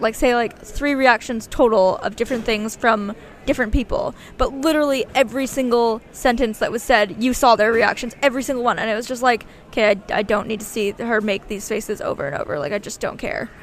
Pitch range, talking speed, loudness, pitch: 215-255 Hz, 225 wpm, -20 LUFS, 230 Hz